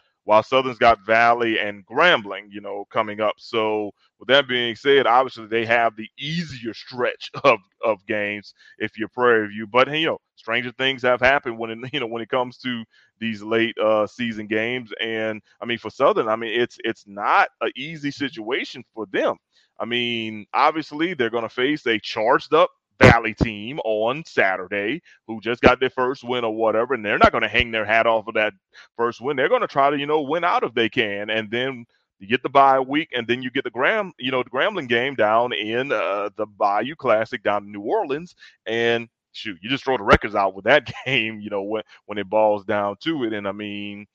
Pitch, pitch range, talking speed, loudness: 115 Hz, 110-125 Hz, 215 wpm, -21 LUFS